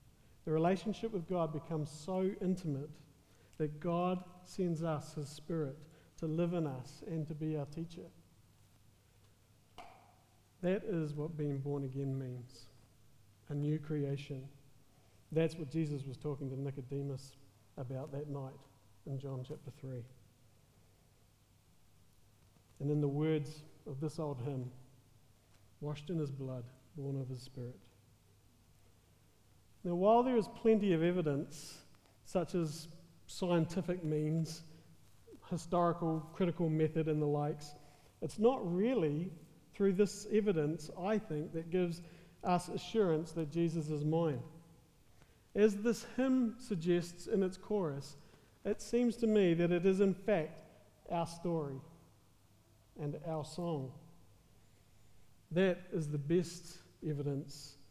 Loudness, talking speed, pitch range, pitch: -37 LUFS, 125 wpm, 130-170 Hz, 150 Hz